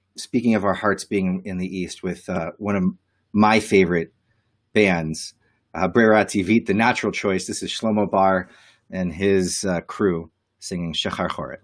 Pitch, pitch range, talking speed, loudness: 100 Hz, 95-110 Hz, 165 wpm, -21 LUFS